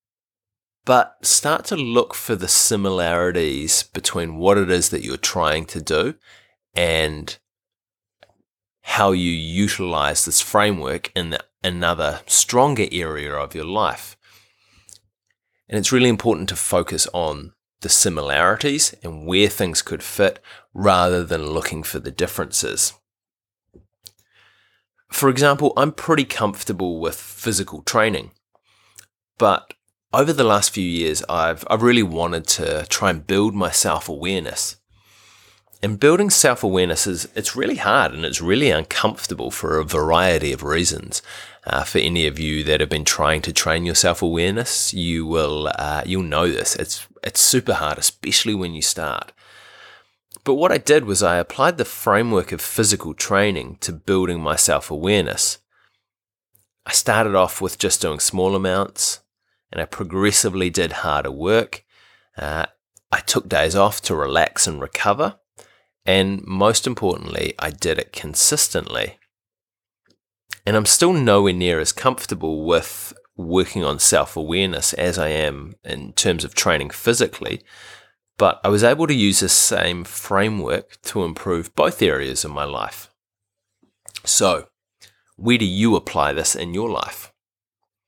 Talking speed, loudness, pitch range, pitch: 145 wpm, -19 LUFS, 85-105 Hz, 95 Hz